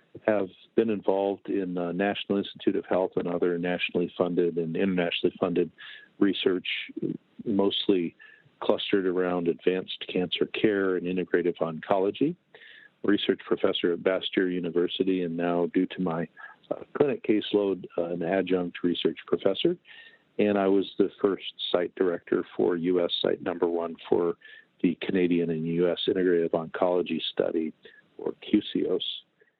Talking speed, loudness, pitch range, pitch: 135 wpm, -27 LUFS, 85-95 Hz, 90 Hz